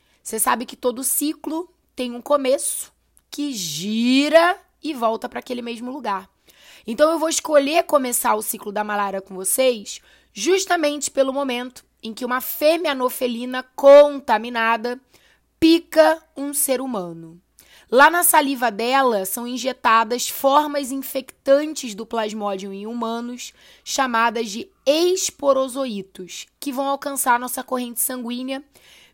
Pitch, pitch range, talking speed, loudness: 255 Hz, 230-290 Hz, 130 wpm, -20 LUFS